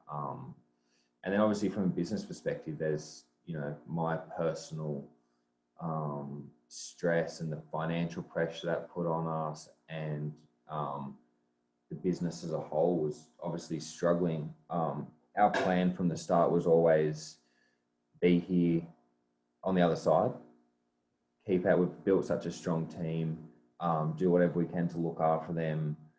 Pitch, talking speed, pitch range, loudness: 80 Hz, 145 wpm, 60-85 Hz, -33 LUFS